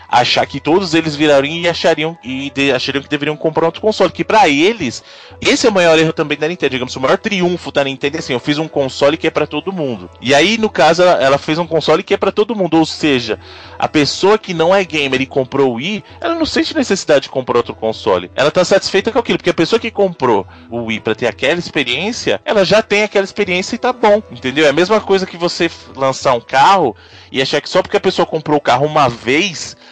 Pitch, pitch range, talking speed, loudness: 160 Hz, 140-195 Hz, 245 wpm, -14 LUFS